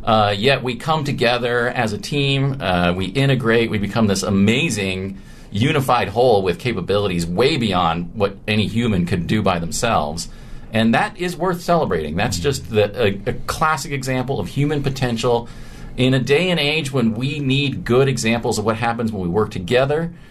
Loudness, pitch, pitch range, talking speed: -19 LUFS, 120 Hz, 105-135 Hz, 175 wpm